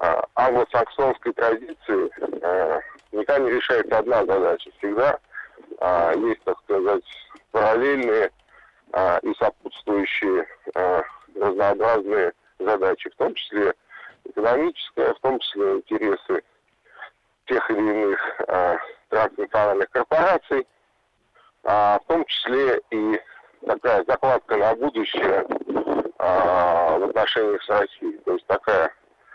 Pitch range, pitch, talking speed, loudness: 355-430 Hz, 395 Hz, 110 wpm, -22 LUFS